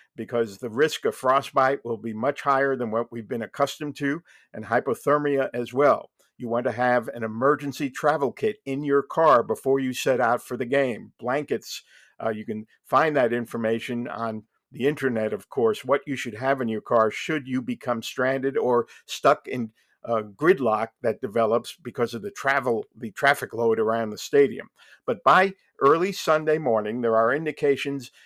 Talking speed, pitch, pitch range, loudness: 180 wpm, 130 Hz, 115-140 Hz, -24 LUFS